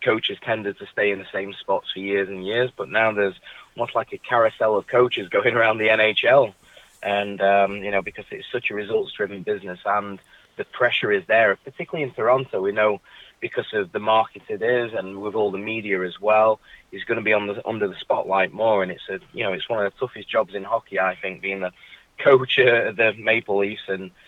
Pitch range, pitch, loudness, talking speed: 100-110 Hz, 105 Hz, -22 LUFS, 225 wpm